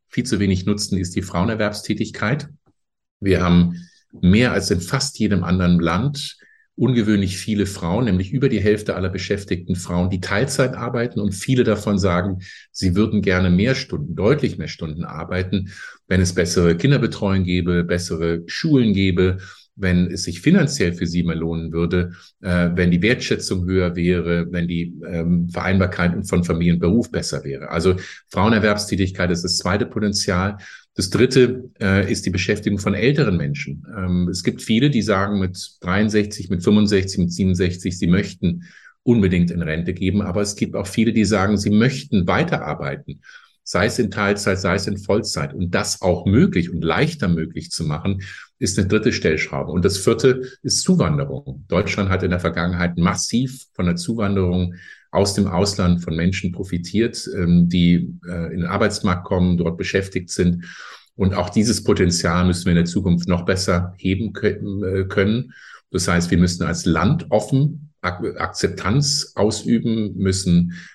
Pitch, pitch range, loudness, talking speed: 95 Hz, 90-105 Hz, -20 LUFS, 155 wpm